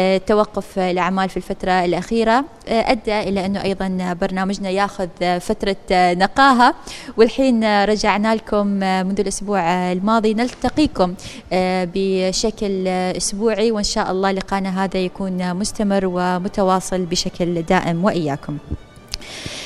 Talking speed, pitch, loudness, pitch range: 100 wpm, 195 Hz, -19 LUFS, 185-215 Hz